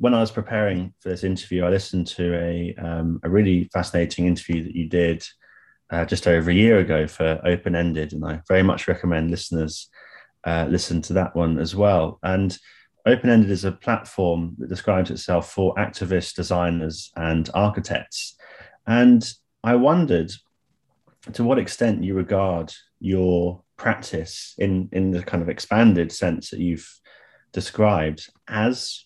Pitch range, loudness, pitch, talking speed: 85-100 Hz, -22 LUFS, 90 Hz, 155 wpm